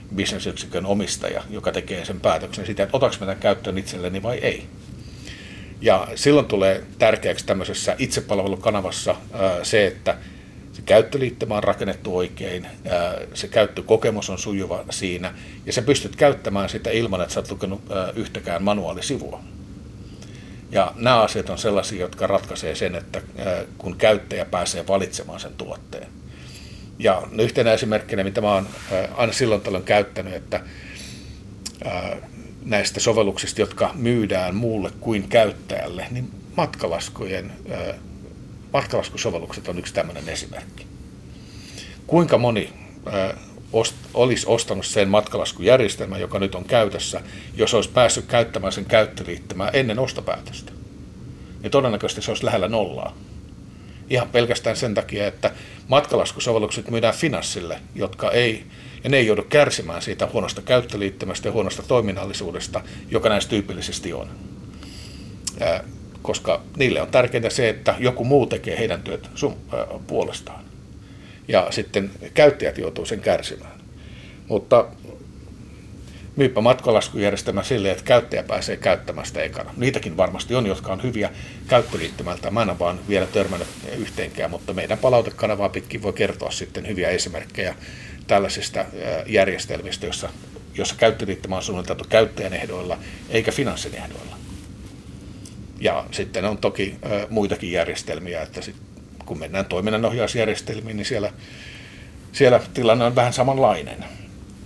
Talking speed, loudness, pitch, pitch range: 125 wpm, -22 LUFS, 105 Hz, 95-115 Hz